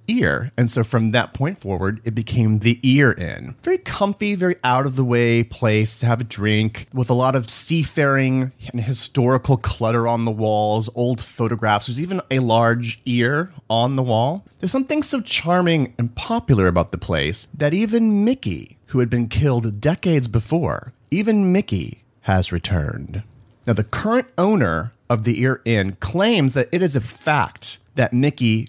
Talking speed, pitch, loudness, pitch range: 175 wpm, 120 Hz, -20 LUFS, 115-145 Hz